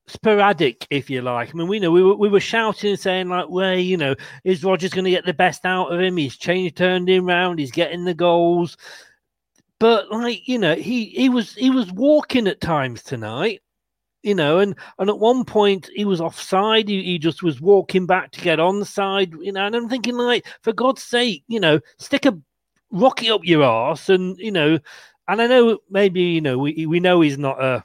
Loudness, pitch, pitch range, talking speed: -19 LUFS, 185 Hz, 170-210 Hz, 225 wpm